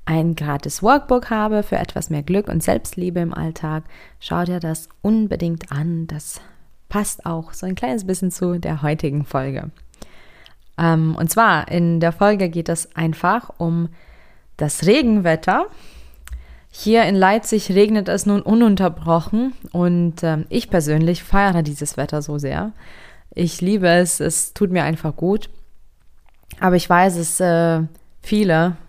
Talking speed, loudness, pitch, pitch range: 140 wpm, -19 LUFS, 170 Hz, 160-195 Hz